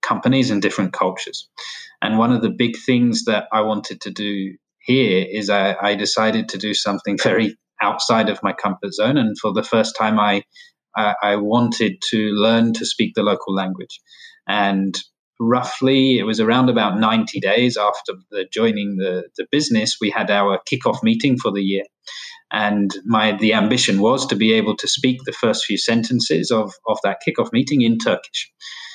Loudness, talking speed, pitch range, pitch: -18 LUFS, 180 wpm, 105-125 Hz, 110 Hz